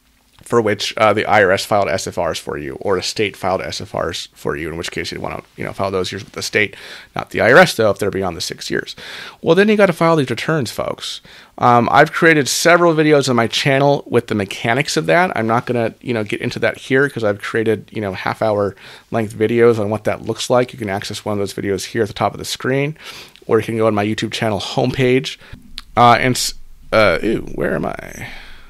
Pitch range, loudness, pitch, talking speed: 110-135 Hz, -16 LUFS, 115 Hz, 240 wpm